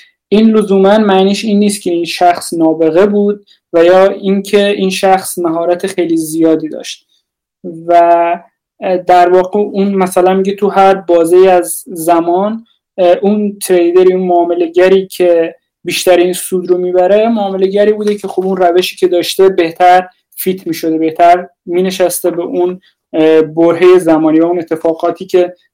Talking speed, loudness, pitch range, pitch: 145 wpm, -10 LUFS, 175-195 Hz, 180 Hz